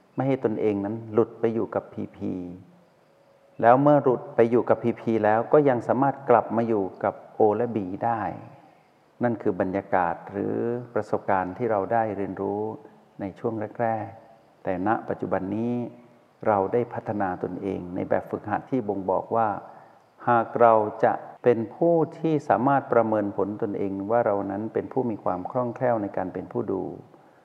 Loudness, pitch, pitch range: -25 LUFS, 115 Hz, 100-120 Hz